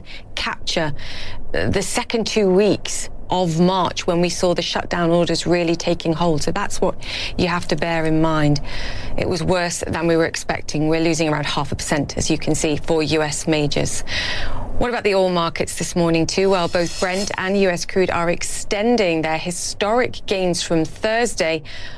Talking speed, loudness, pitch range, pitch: 180 wpm, -20 LUFS, 160-185 Hz, 170 Hz